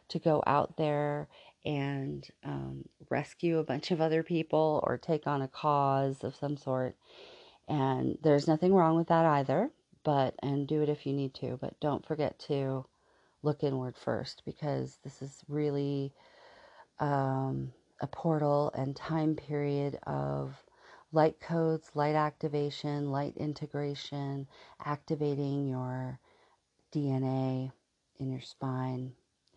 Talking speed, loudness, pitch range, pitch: 130 wpm, -32 LUFS, 135-150 Hz, 145 Hz